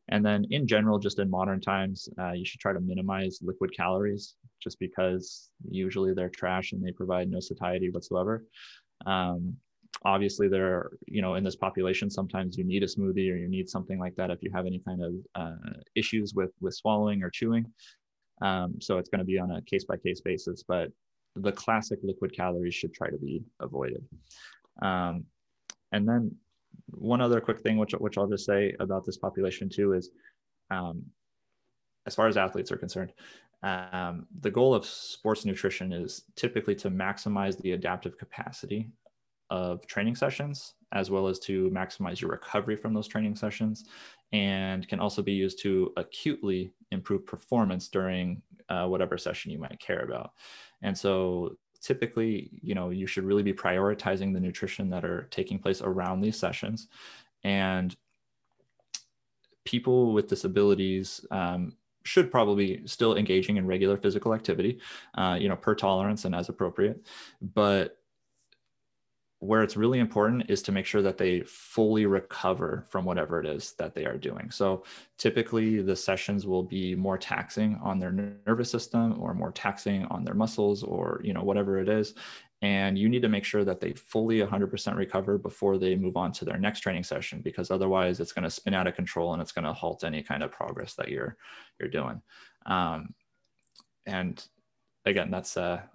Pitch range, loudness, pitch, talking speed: 95-105 Hz, -30 LUFS, 95 Hz, 175 wpm